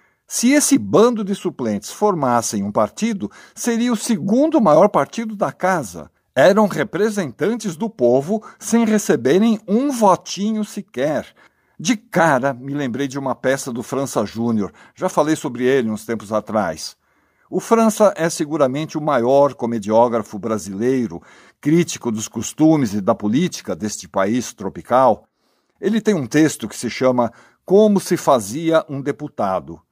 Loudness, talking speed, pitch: -18 LUFS, 140 wpm, 155 Hz